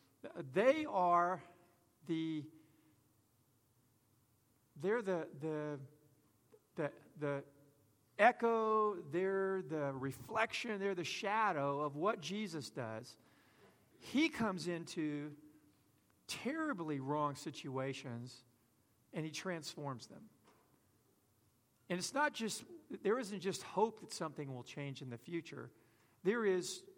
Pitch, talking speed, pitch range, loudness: 150 Hz, 100 wpm, 125-185 Hz, -39 LUFS